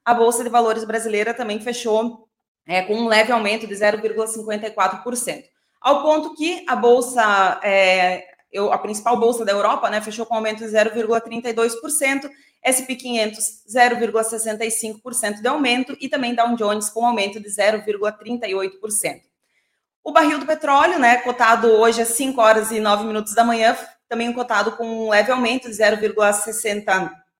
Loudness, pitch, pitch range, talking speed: -19 LUFS, 225 Hz, 215-240 Hz, 150 wpm